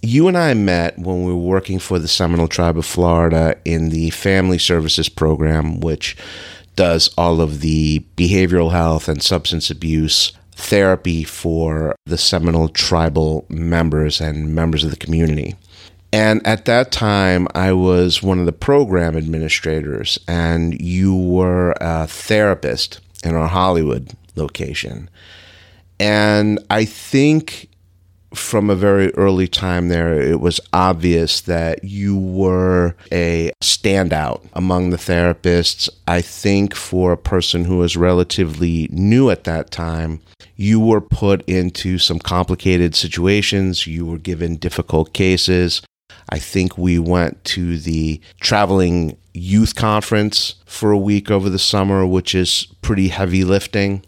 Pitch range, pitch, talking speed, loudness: 85-95 Hz, 90 Hz, 140 wpm, -16 LUFS